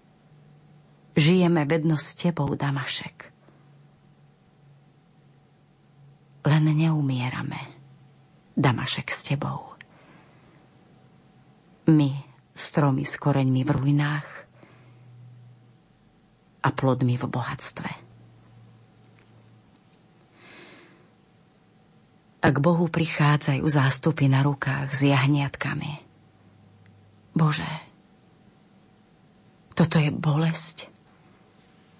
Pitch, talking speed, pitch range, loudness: 145 Hz, 60 wpm, 135-155 Hz, -24 LUFS